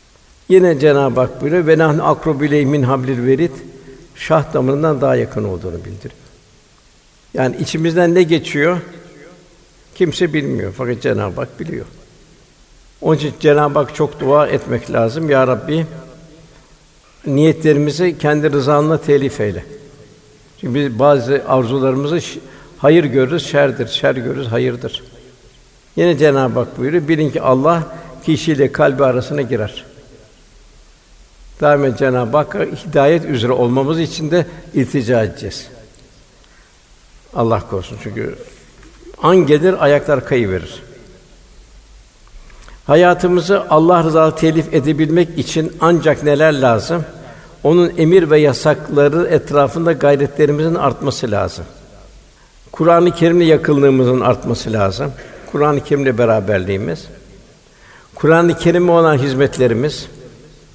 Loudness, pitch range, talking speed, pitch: -14 LUFS, 130-160 Hz, 105 wpm, 145 Hz